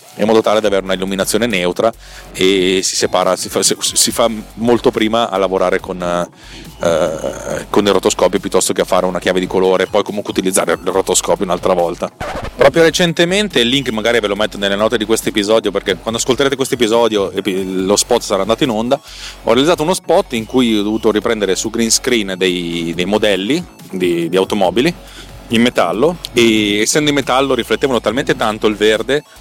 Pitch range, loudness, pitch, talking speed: 95-115 Hz, -14 LUFS, 110 Hz, 190 wpm